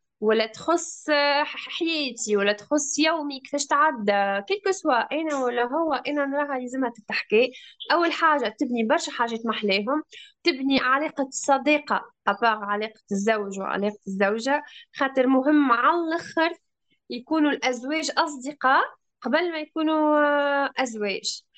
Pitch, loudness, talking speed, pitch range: 280 Hz, -24 LUFS, 110 wpm, 235-310 Hz